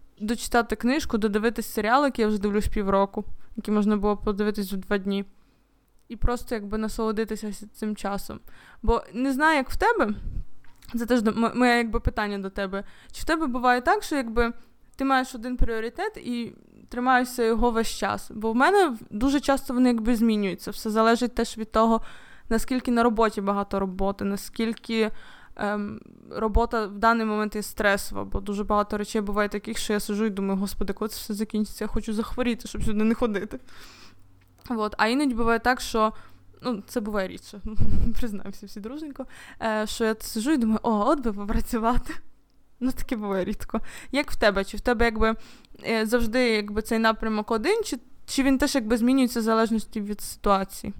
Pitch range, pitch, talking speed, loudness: 210-245 Hz, 225 Hz, 175 wpm, -25 LUFS